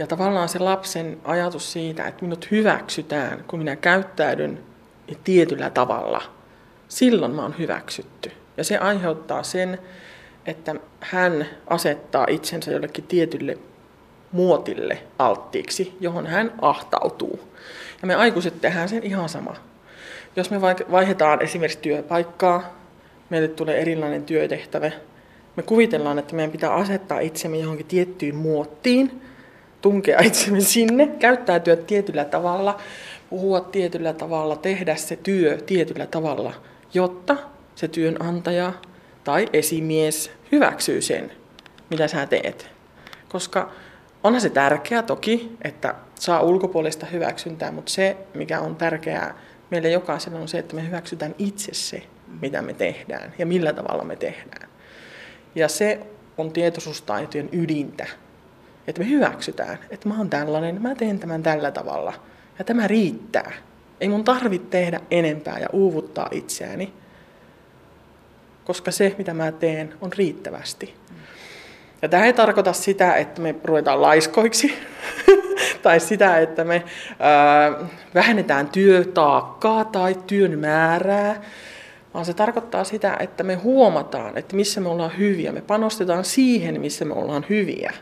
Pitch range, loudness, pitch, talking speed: 160-200 Hz, -21 LUFS, 175 Hz, 130 wpm